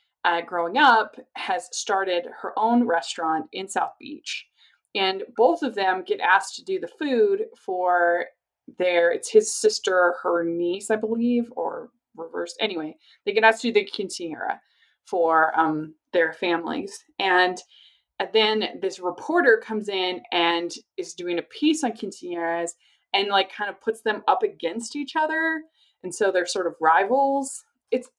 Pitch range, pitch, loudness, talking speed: 175-285 Hz, 205 Hz, -23 LUFS, 160 wpm